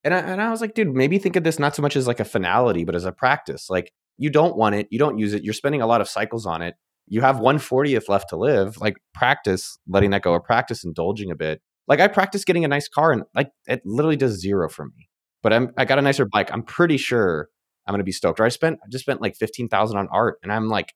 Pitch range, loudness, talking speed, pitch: 100-145 Hz, -21 LUFS, 280 wpm, 115 Hz